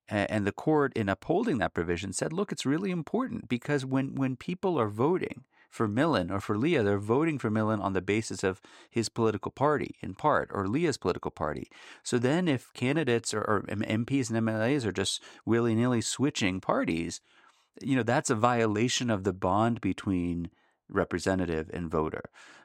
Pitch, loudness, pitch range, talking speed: 110 Hz, -29 LUFS, 95-130 Hz, 180 wpm